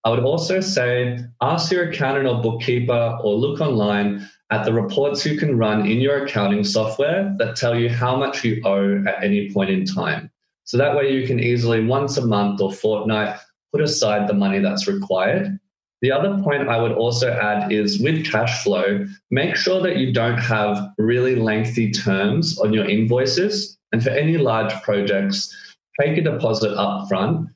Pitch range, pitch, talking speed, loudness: 105-145 Hz, 120 Hz, 185 wpm, -20 LUFS